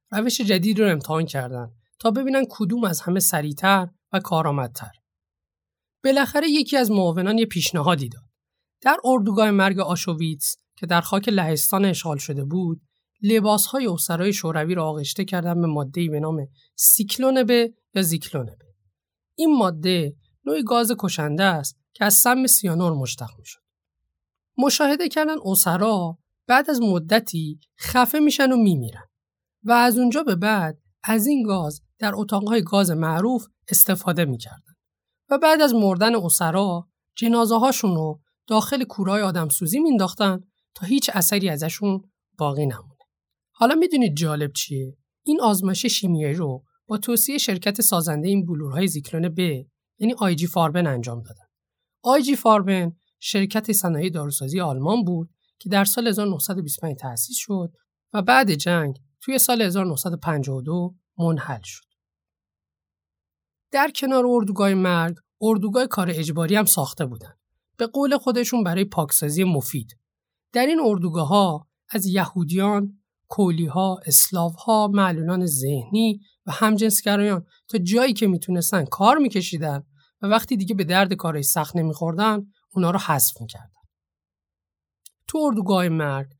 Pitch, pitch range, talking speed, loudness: 185 Hz, 150-220 Hz, 135 wpm, -21 LUFS